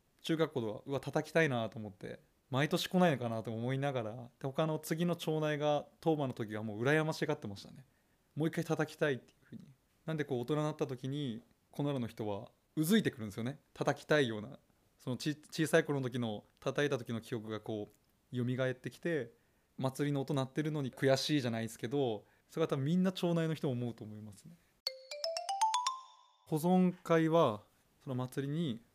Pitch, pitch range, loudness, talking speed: 140 Hz, 120-160 Hz, -36 LUFS, 375 characters per minute